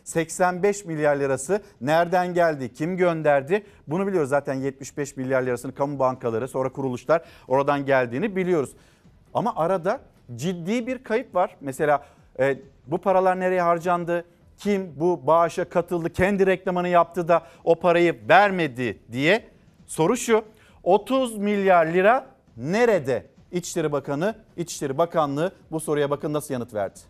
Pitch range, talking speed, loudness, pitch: 140-185 Hz, 135 wpm, -23 LUFS, 170 Hz